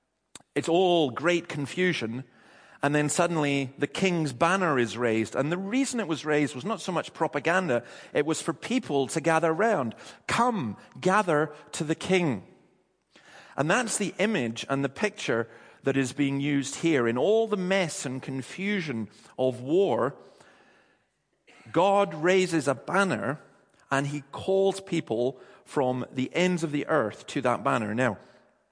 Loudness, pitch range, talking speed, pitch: -27 LUFS, 135-185 Hz, 155 wpm, 155 Hz